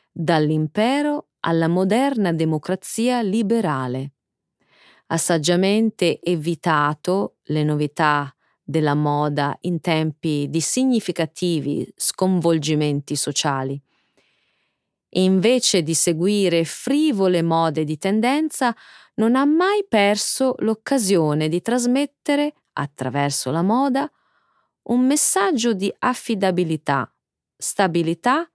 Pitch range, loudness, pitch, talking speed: 155-235 Hz, -20 LUFS, 180 Hz, 90 wpm